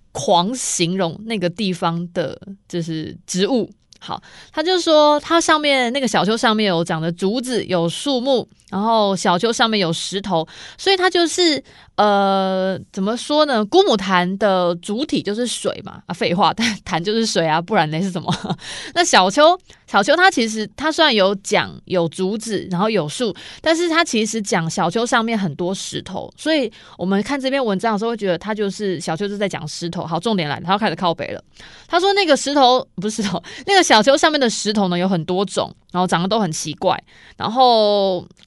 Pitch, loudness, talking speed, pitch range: 205 Hz, -18 LUFS, 285 characters per minute, 180-250 Hz